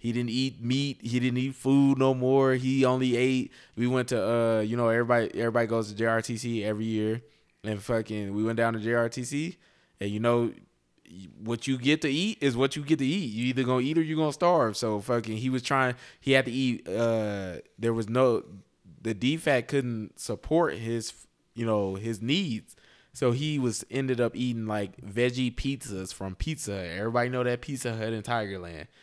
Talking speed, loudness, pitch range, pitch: 195 wpm, -28 LUFS, 110-130 Hz, 120 Hz